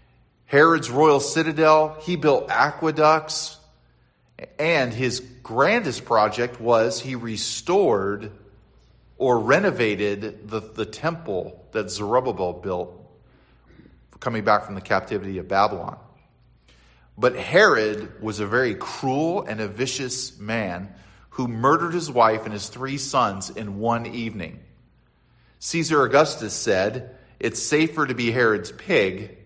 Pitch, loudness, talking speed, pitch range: 115 Hz, -22 LUFS, 120 wpm, 105-140 Hz